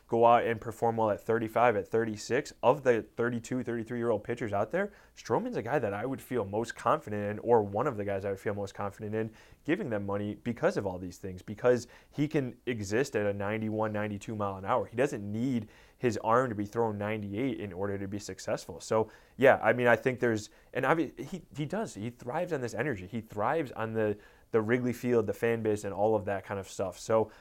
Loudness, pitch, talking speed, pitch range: -31 LUFS, 110 Hz, 235 wpm, 105-120 Hz